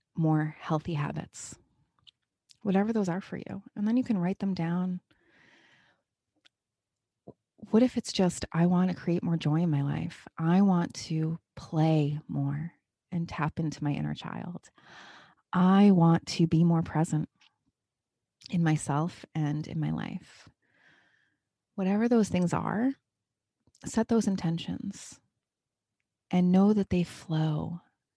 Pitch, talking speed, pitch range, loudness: 170 Hz, 135 wpm, 155-190 Hz, -28 LUFS